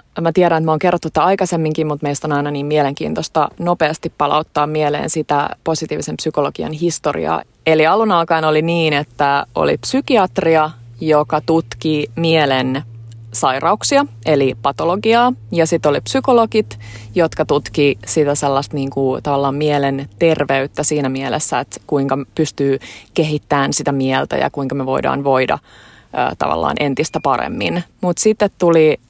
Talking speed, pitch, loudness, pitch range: 140 wpm, 150 Hz, -16 LUFS, 140-165 Hz